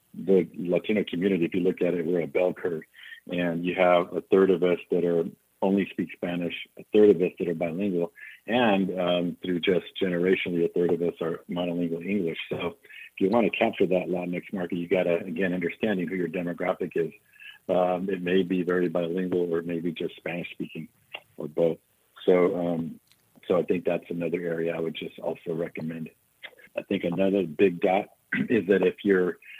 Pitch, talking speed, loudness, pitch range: 90 Hz, 195 wpm, -26 LUFS, 85-95 Hz